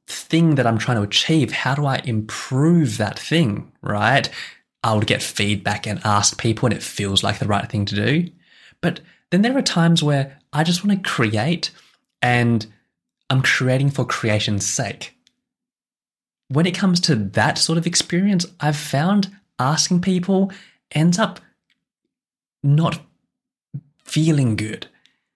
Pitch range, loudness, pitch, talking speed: 115-175 Hz, -19 LUFS, 150 Hz, 150 wpm